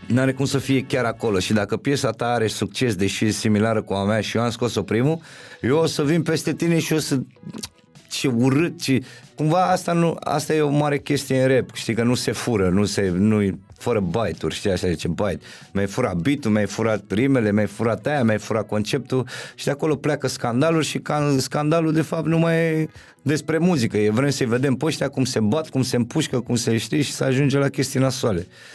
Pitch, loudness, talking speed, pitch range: 130 Hz, -21 LUFS, 230 wpm, 110-150 Hz